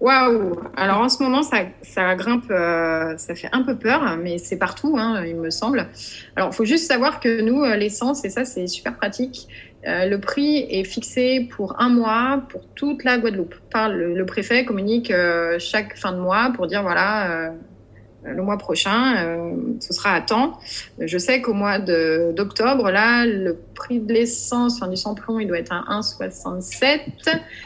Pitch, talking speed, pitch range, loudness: 210 Hz, 175 wpm, 180-245 Hz, -21 LUFS